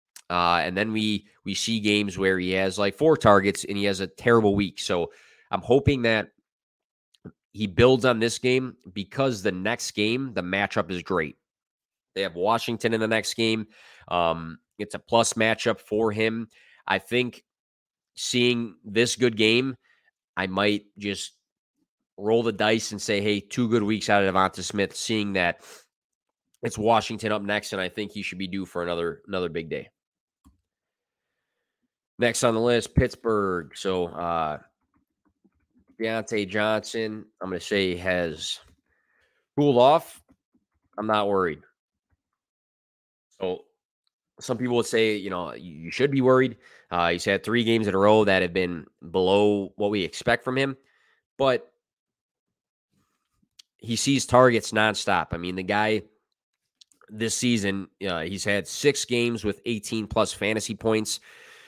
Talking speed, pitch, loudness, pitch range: 155 wpm, 105 Hz, -24 LUFS, 100-115 Hz